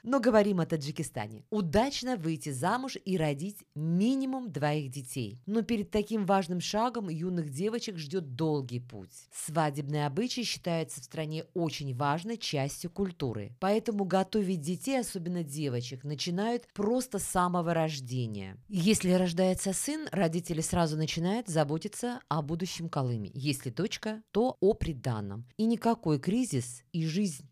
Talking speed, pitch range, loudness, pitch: 135 wpm, 150-210 Hz, -32 LUFS, 175 Hz